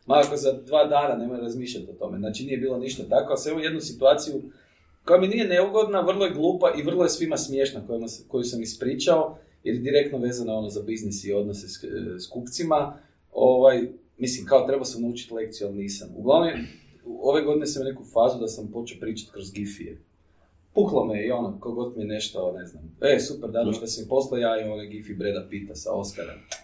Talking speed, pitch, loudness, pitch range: 205 wpm, 120 Hz, -25 LUFS, 105-140 Hz